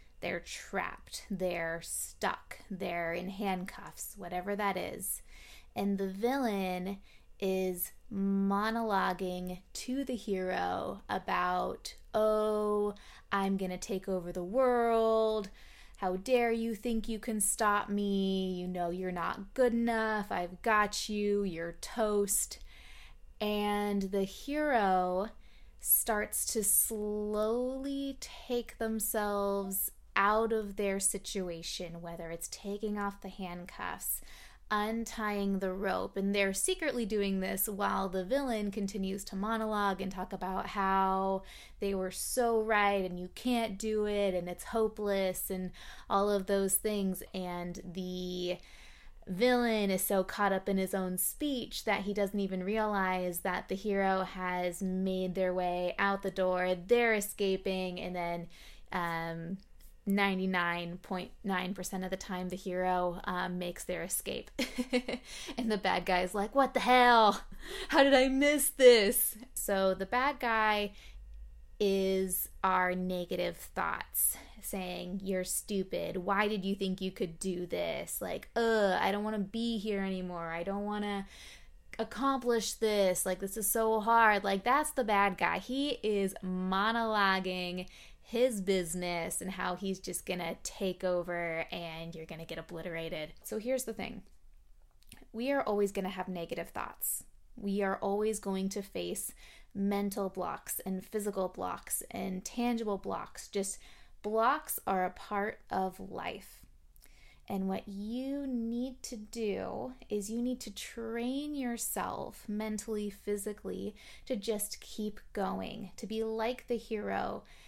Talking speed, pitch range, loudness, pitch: 140 wpm, 185-220 Hz, -33 LUFS, 200 Hz